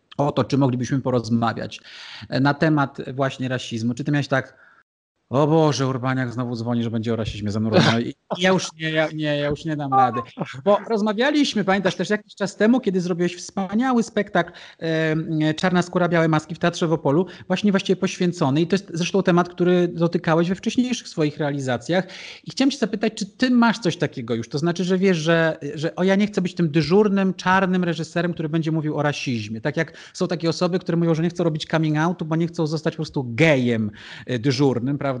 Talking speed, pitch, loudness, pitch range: 205 wpm, 165 Hz, -22 LUFS, 140-185 Hz